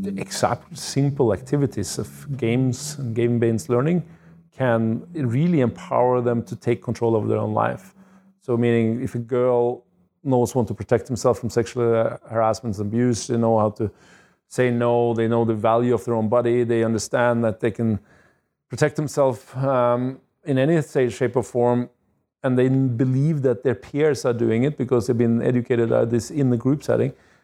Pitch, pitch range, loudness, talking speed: 120 Hz, 115-135 Hz, -22 LUFS, 175 wpm